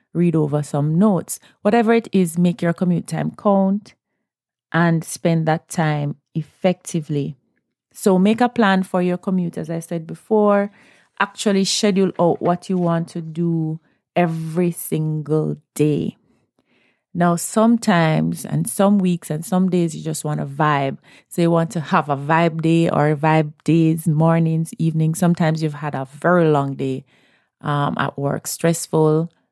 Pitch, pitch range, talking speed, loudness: 165 Hz, 155-185 Hz, 155 wpm, -19 LUFS